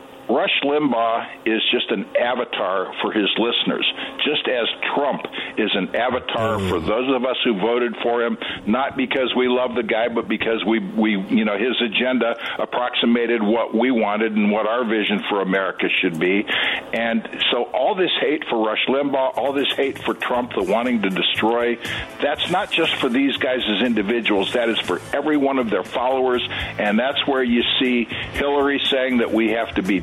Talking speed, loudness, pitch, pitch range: 190 wpm, -20 LUFS, 120 Hz, 110-130 Hz